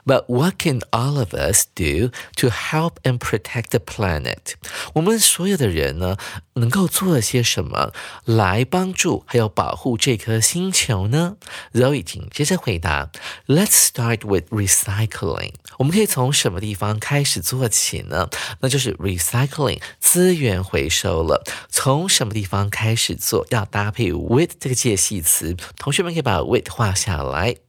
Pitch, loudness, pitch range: 120 Hz, -19 LUFS, 100-145 Hz